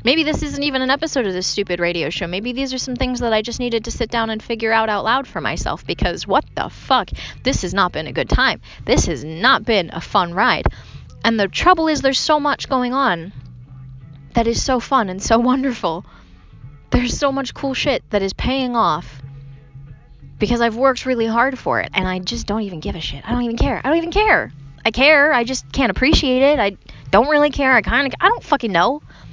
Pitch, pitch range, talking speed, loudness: 230 Hz, 180-265 Hz, 235 wpm, -18 LUFS